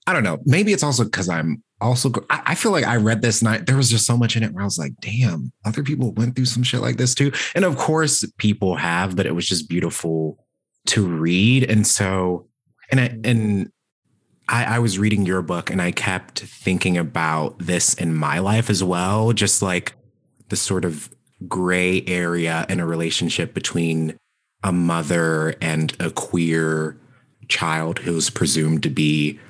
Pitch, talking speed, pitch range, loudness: 95 Hz, 185 wpm, 85-115 Hz, -20 LUFS